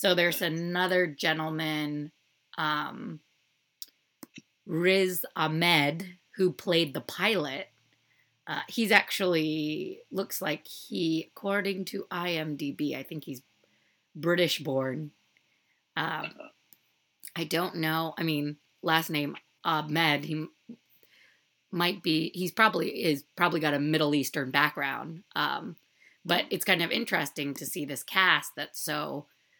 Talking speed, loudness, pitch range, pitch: 115 wpm, -29 LUFS, 150-180 Hz, 160 Hz